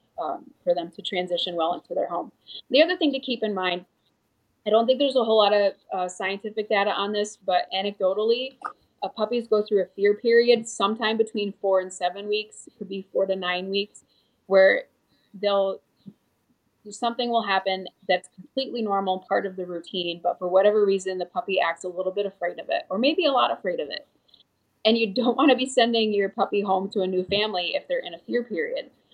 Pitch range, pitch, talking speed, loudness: 190-230 Hz, 205 Hz, 210 wpm, -24 LUFS